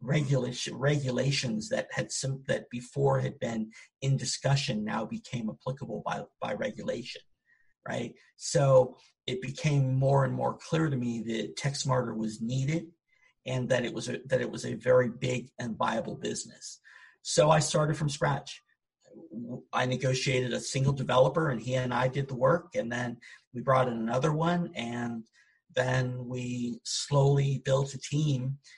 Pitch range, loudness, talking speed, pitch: 125-140 Hz, -30 LUFS, 160 wpm, 130 Hz